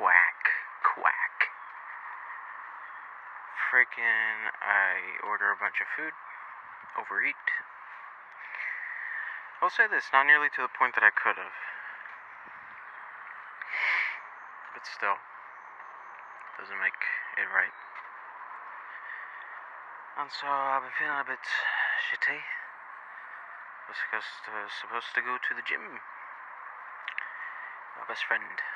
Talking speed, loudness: 100 wpm, -29 LUFS